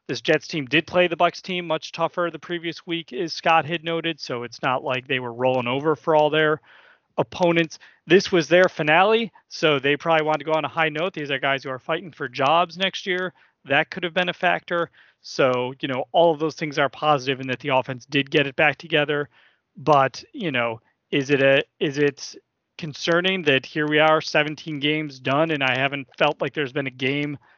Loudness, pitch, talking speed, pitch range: -22 LUFS, 155 Hz, 220 wpm, 140-170 Hz